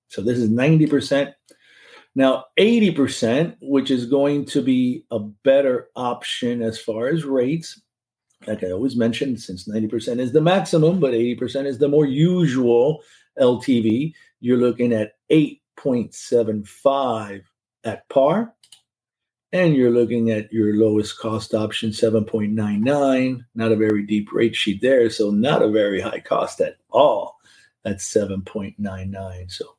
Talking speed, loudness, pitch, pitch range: 160 wpm, -20 LUFS, 120 Hz, 110-140 Hz